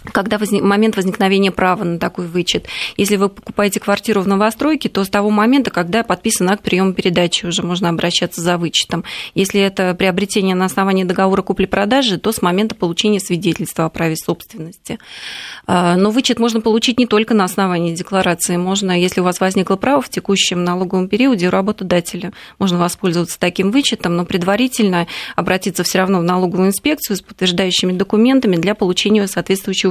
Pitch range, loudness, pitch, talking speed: 180-210 Hz, -15 LUFS, 190 Hz, 165 wpm